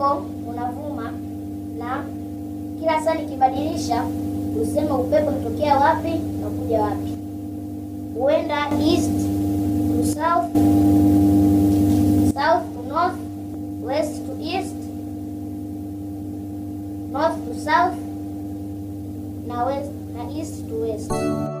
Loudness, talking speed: -22 LUFS, 80 wpm